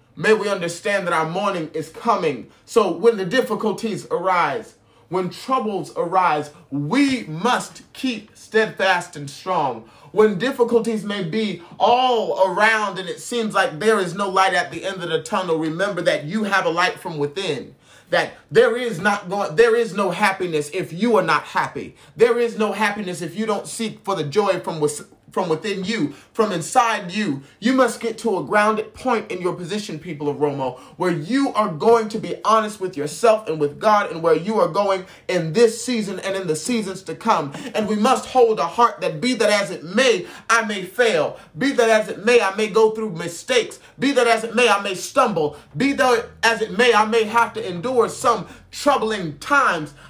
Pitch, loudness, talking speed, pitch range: 210 Hz, -20 LUFS, 200 wpm, 180-230 Hz